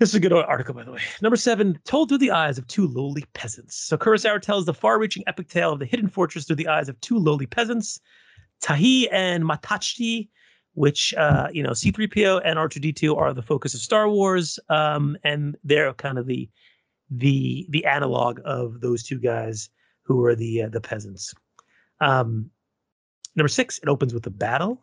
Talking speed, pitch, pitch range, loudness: 190 wpm, 150 Hz, 125-195 Hz, -22 LUFS